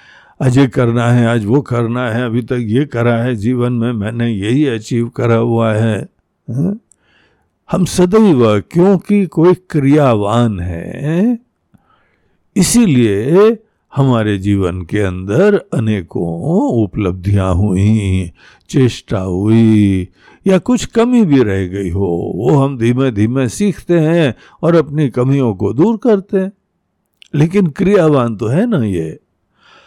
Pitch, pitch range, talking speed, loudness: 125 Hz, 110-170 Hz, 125 wpm, -13 LUFS